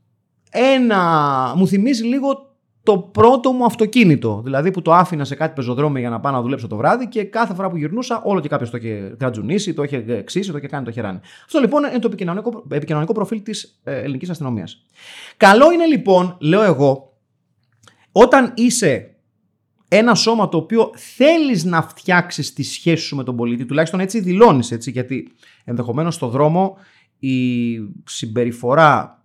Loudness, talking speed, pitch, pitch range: -17 LUFS, 165 wpm, 165 Hz, 130-220 Hz